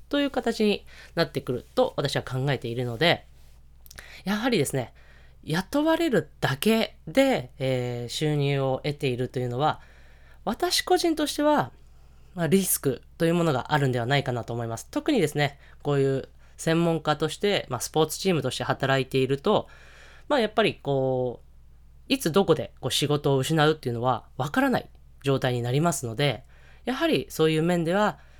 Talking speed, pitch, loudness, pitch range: 330 characters per minute, 140 Hz, -26 LUFS, 125-175 Hz